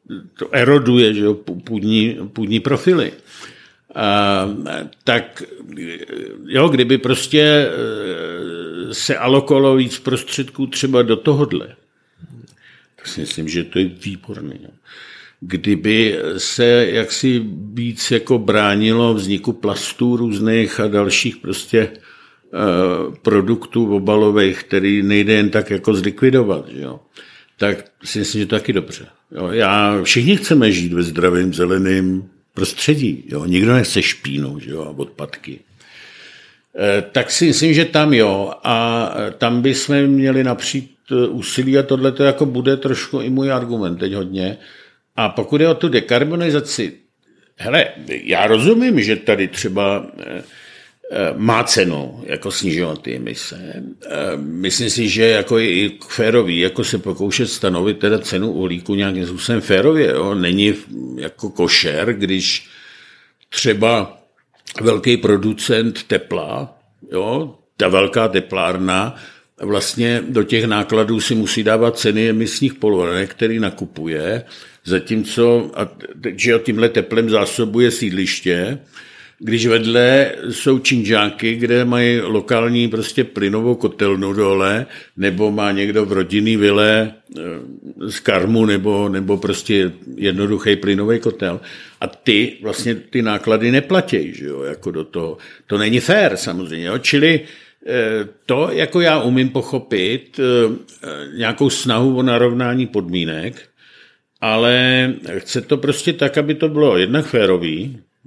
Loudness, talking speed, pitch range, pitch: -16 LUFS, 125 wpm, 100-130 Hz, 115 Hz